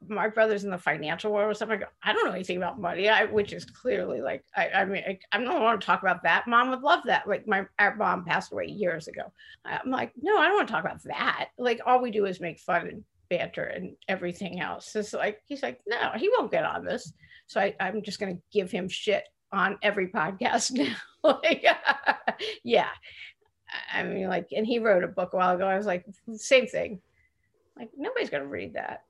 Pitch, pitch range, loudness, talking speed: 220 Hz, 190-280 Hz, -27 LUFS, 230 wpm